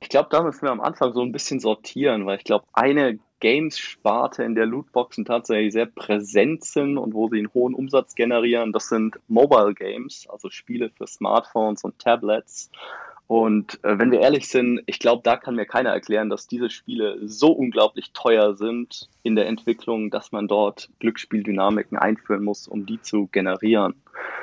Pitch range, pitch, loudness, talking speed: 105-120 Hz, 115 Hz, -22 LUFS, 180 wpm